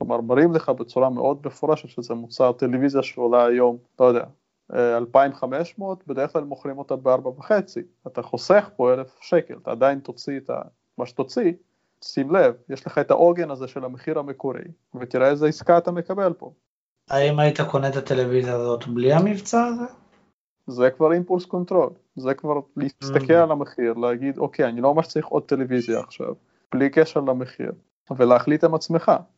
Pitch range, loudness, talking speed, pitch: 130-165 Hz, -22 LUFS, 160 wpm, 140 Hz